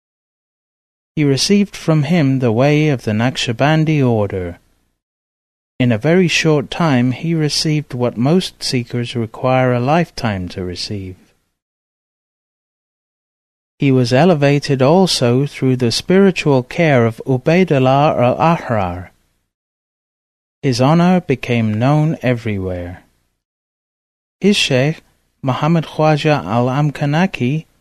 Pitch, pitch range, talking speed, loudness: 130 Hz, 115-155 Hz, 105 wpm, -15 LUFS